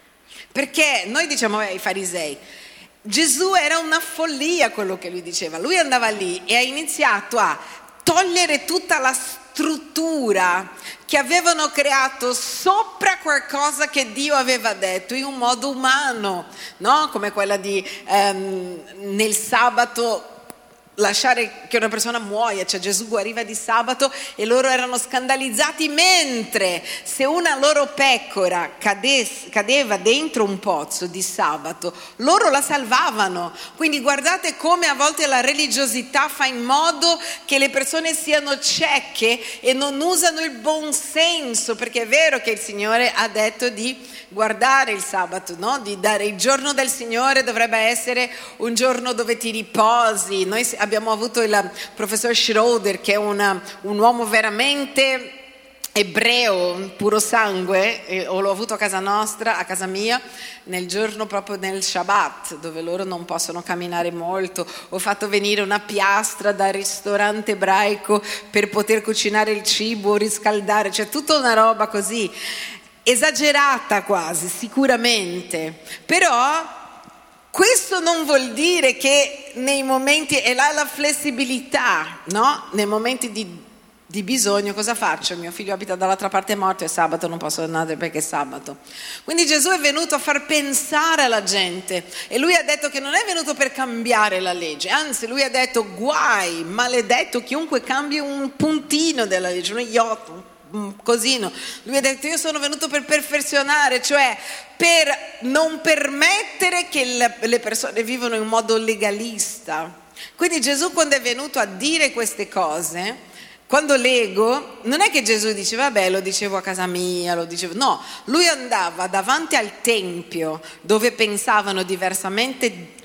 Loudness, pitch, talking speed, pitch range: -19 LUFS, 235 Hz, 145 wpm, 200-280 Hz